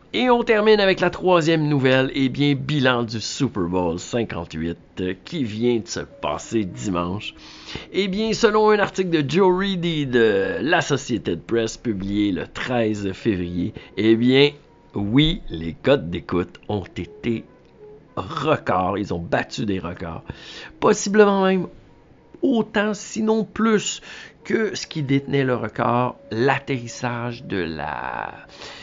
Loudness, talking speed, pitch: -21 LUFS, 135 wpm, 125 Hz